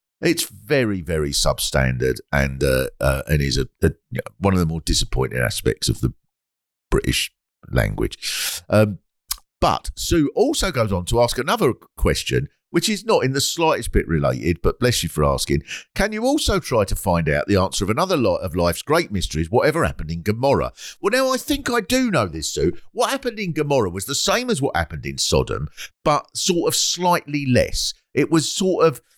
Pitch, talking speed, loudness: 100 Hz, 195 wpm, -21 LUFS